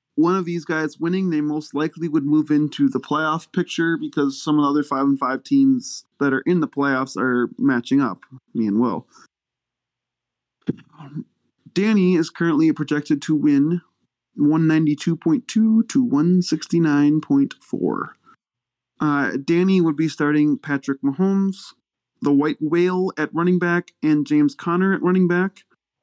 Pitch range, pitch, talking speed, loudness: 145-180 Hz, 155 Hz, 145 wpm, -20 LUFS